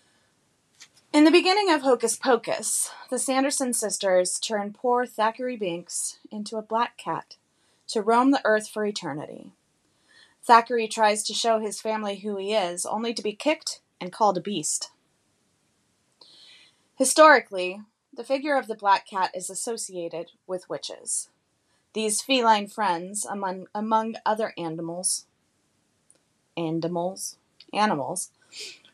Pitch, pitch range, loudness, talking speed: 215 Hz, 190-245 Hz, -24 LUFS, 125 wpm